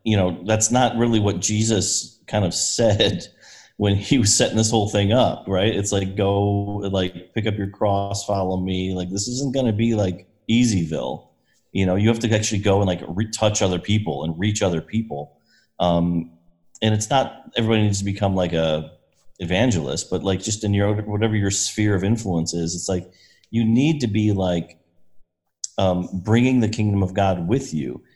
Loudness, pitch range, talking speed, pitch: -21 LUFS, 90-110 Hz, 190 wpm, 100 Hz